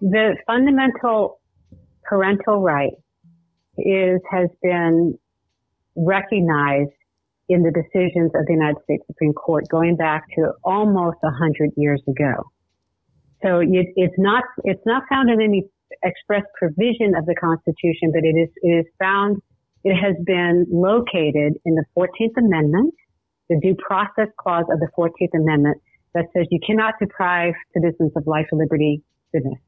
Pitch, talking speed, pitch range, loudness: 175 Hz, 140 wpm, 160-195 Hz, -19 LUFS